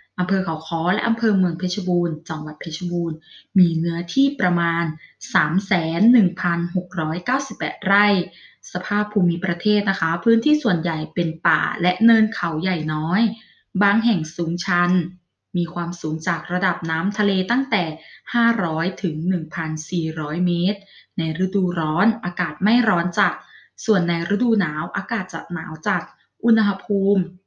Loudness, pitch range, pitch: -21 LUFS, 170-205 Hz, 180 Hz